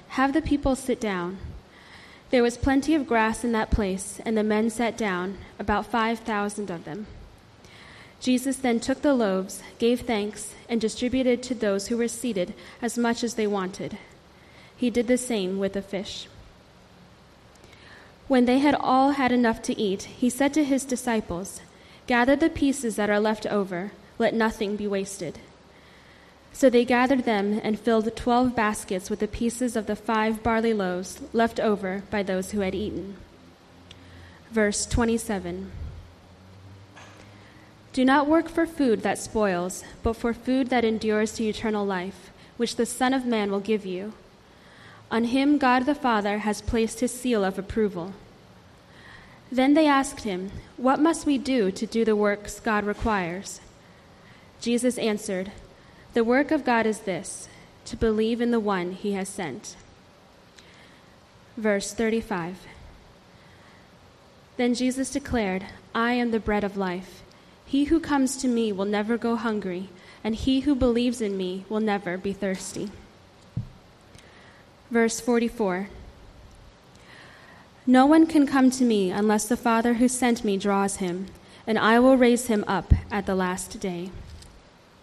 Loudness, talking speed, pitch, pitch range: -25 LUFS, 155 wpm, 220 Hz, 195-245 Hz